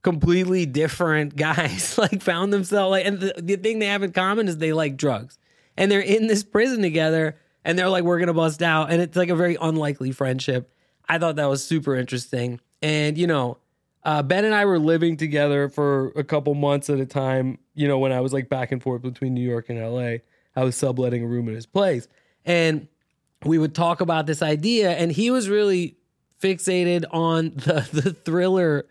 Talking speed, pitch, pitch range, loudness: 210 wpm, 160 Hz, 140-180 Hz, -22 LUFS